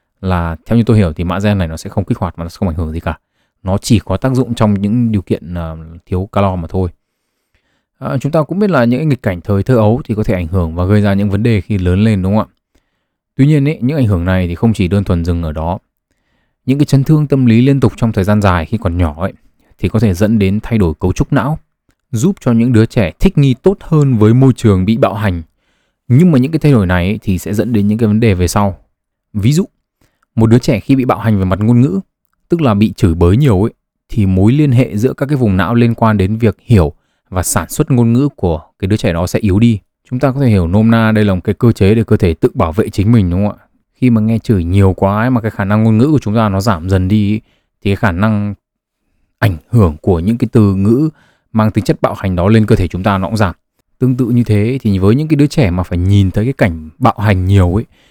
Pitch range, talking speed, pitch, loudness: 95-120 Hz, 285 wpm, 110 Hz, -13 LUFS